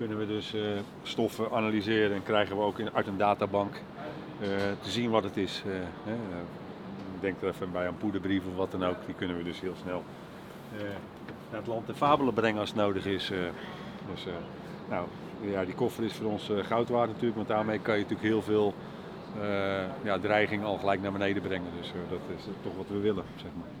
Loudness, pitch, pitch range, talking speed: -32 LUFS, 105 Hz, 95-110 Hz, 195 wpm